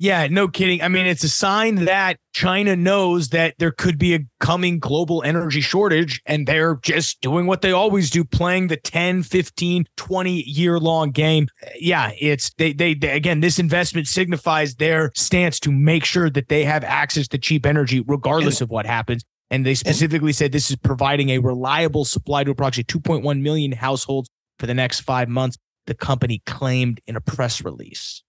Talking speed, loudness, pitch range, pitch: 185 wpm, -19 LUFS, 135-175 Hz, 155 Hz